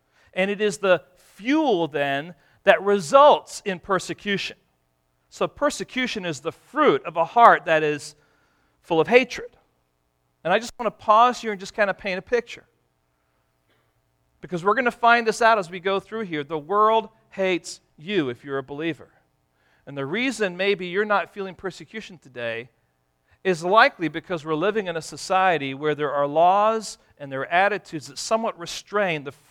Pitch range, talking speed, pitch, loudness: 140-210 Hz, 175 wpm, 175 Hz, -22 LUFS